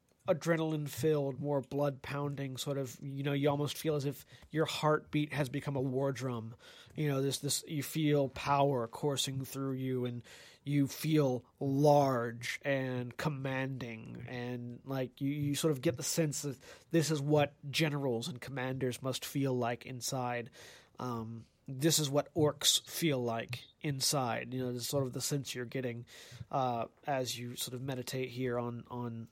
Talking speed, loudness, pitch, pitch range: 160 wpm, -34 LUFS, 135 Hz, 125-145 Hz